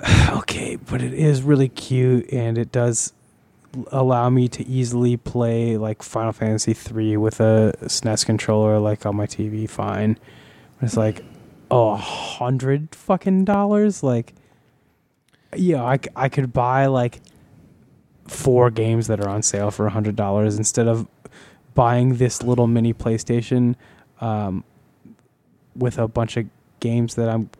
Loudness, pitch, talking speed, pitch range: -20 LUFS, 120 Hz, 145 wpm, 110-130 Hz